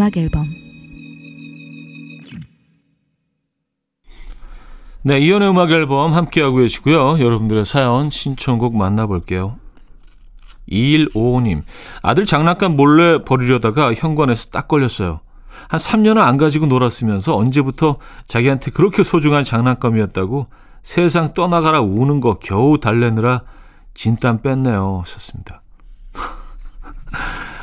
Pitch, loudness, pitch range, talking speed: 130 Hz, -15 LUFS, 115-155 Hz, 240 characters per minute